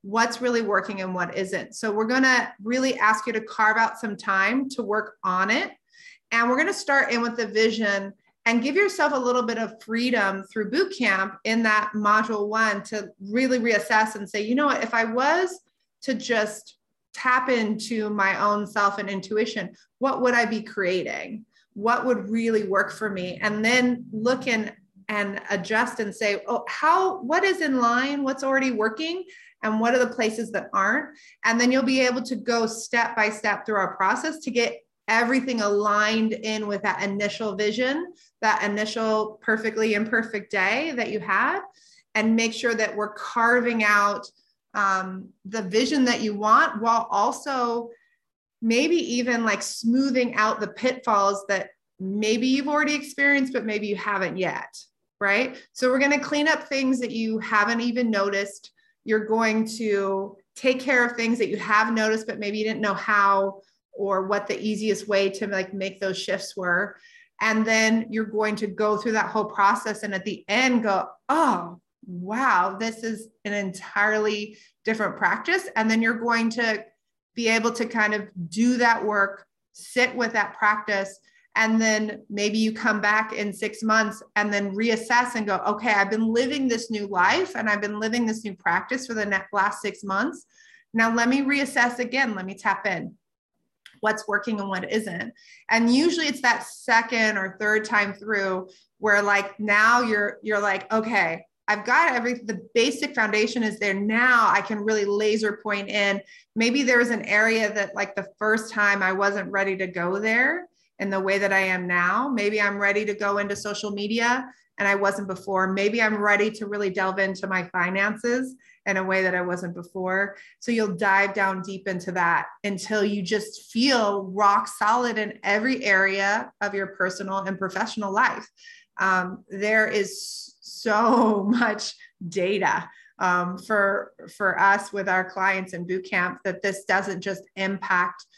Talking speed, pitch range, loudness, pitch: 180 wpm, 200-235 Hz, -23 LUFS, 215 Hz